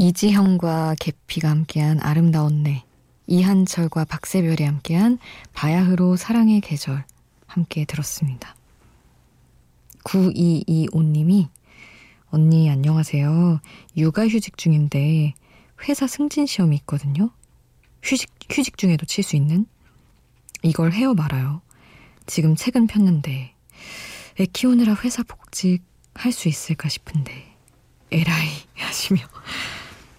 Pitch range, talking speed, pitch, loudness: 150-190 Hz, 235 characters per minute, 165 Hz, -20 LUFS